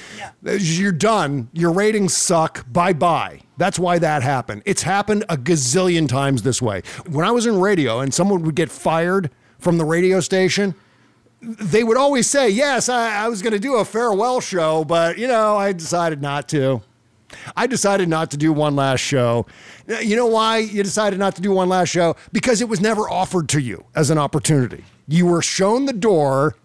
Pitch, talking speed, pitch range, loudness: 175 Hz, 195 wpm, 150-210 Hz, -18 LUFS